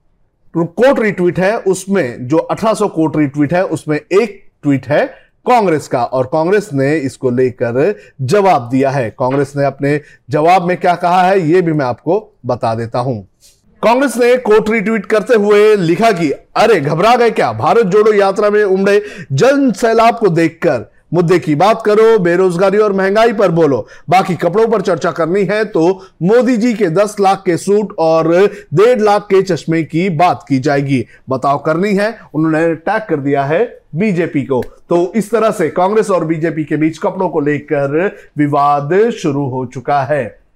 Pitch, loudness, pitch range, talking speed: 180 Hz, -13 LUFS, 150-210 Hz, 175 wpm